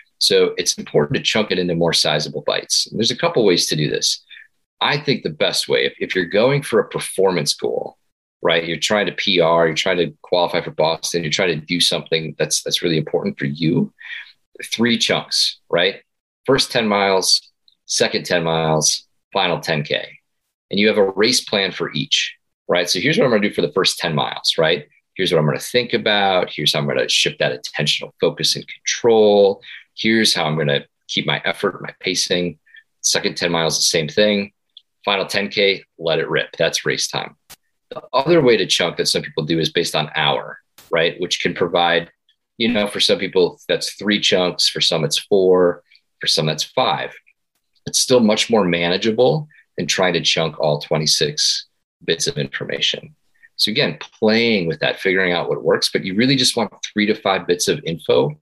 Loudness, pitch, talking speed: -18 LUFS, 110 Hz, 200 wpm